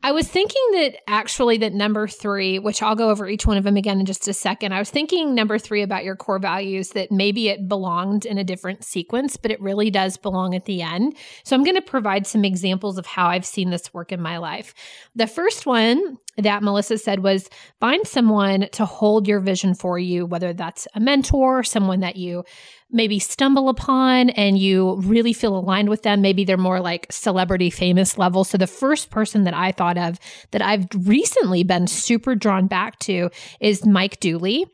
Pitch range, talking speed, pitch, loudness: 185-225 Hz, 205 wpm, 200 Hz, -20 LUFS